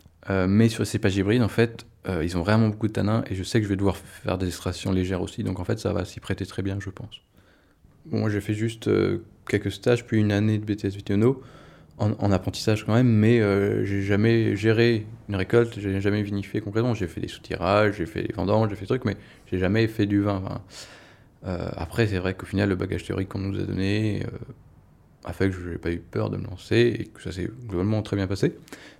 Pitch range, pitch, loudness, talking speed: 95-110 Hz, 100 Hz, -25 LUFS, 250 wpm